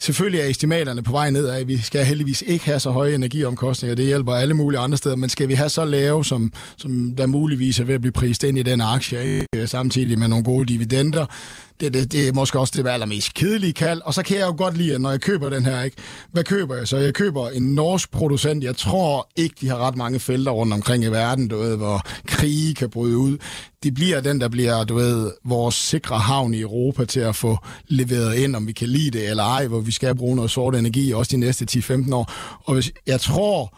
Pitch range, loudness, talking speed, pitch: 120-145 Hz, -21 LUFS, 250 wpm, 130 Hz